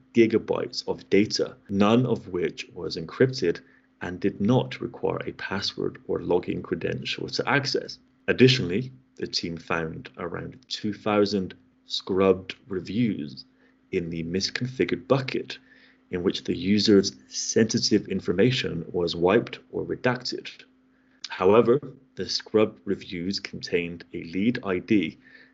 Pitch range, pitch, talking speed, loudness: 90-120 Hz, 100 Hz, 115 wpm, -26 LUFS